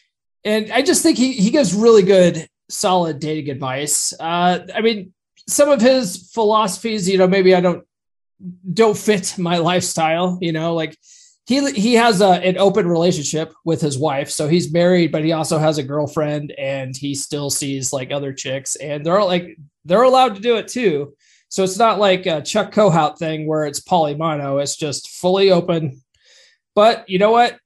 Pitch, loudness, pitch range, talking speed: 180 Hz, -17 LUFS, 155-210 Hz, 185 wpm